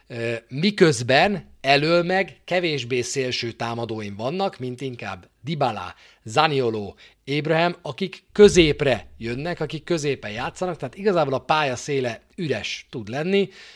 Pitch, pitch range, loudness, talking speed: 145 Hz, 125-175 Hz, -22 LUFS, 115 wpm